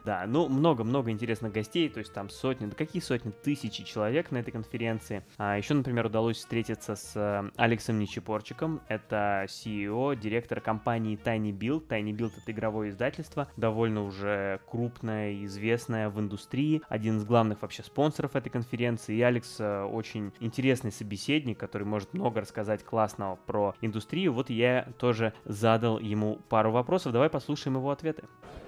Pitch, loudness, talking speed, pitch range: 115 Hz, -31 LUFS, 150 wpm, 105-125 Hz